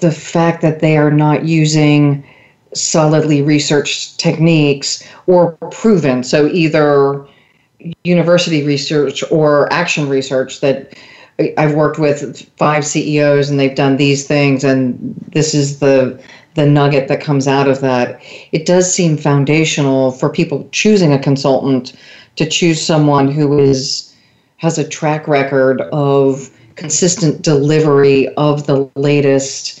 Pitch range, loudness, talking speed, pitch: 140-155 Hz, -13 LUFS, 130 wpm, 145 Hz